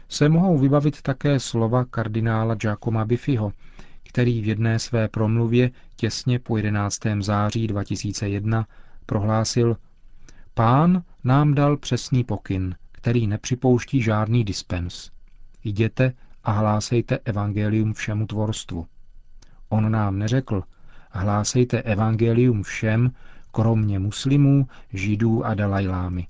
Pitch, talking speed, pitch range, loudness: 110 Hz, 105 wpm, 105-125 Hz, -22 LUFS